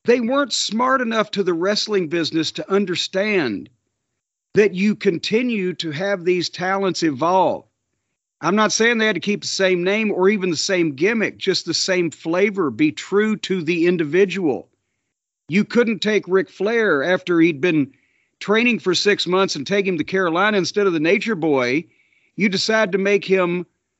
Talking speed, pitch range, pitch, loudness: 175 wpm, 175-210 Hz, 190 Hz, -19 LUFS